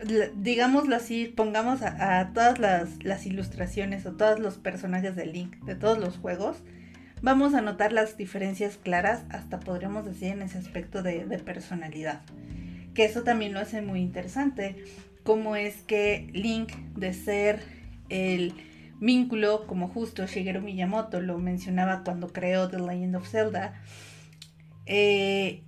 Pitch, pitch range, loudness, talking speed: 195 Hz, 180-215 Hz, -28 LUFS, 145 wpm